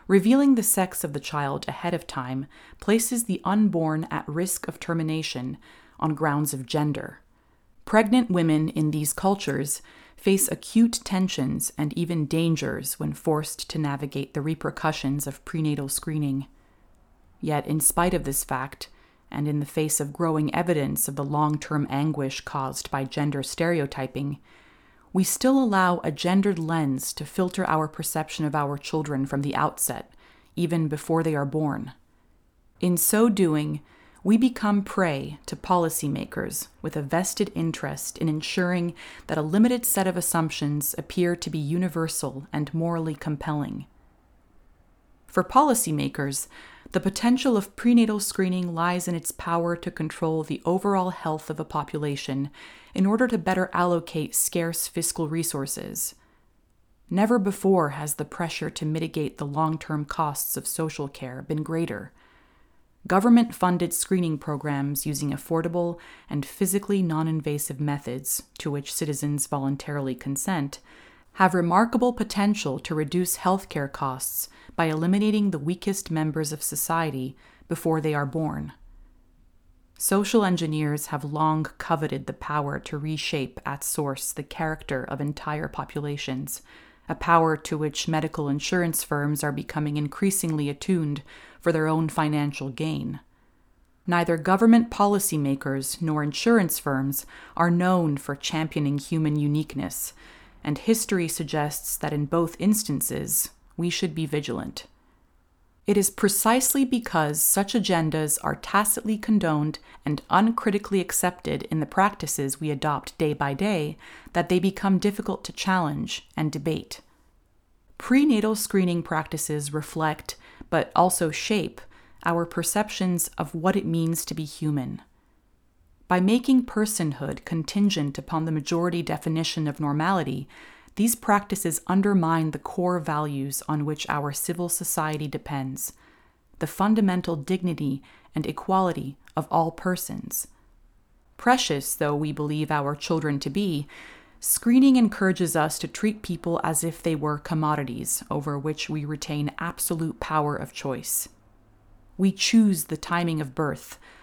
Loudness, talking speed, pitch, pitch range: -25 LUFS, 135 wpm, 160 Hz, 145-185 Hz